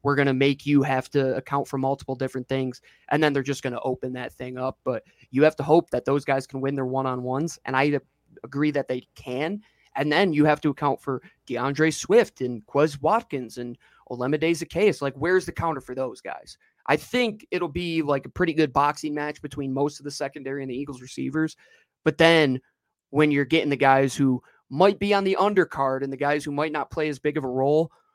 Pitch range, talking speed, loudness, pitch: 130-155 Hz, 230 wpm, -24 LUFS, 140 Hz